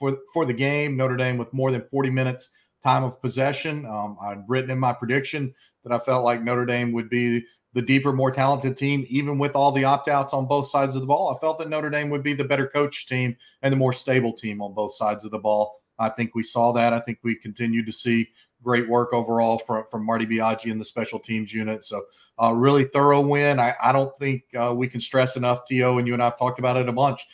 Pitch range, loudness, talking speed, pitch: 115-135 Hz, -23 LUFS, 245 wpm, 125 Hz